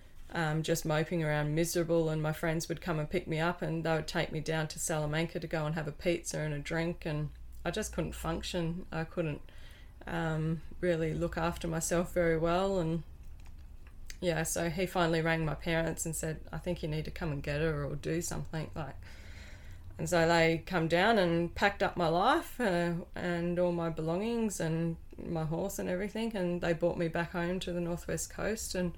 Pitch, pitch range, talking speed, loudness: 165 Hz, 155-175 Hz, 205 wpm, -33 LUFS